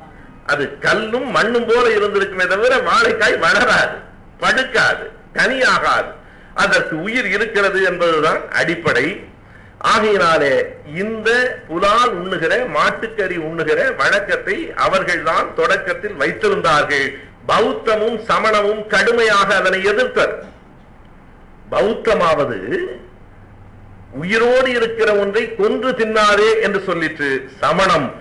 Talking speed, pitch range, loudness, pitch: 85 wpm, 190-255 Hz, -16 LUFS, 220 Hz